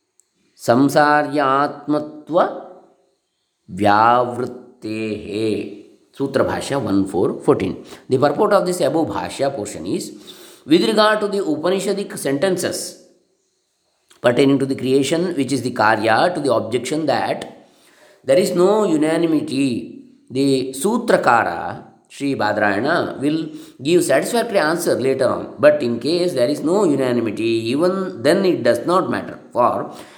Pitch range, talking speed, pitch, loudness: 135-190 Hz, 115 wpm, 150 Hz, -18 LUFS